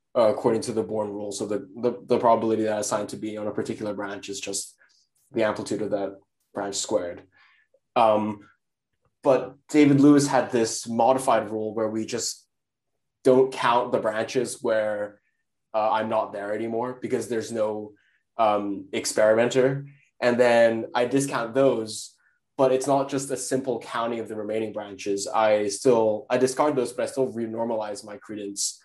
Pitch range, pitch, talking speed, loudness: 105-125 Hz, 110 Hz, 165 wpm, -24 LUFS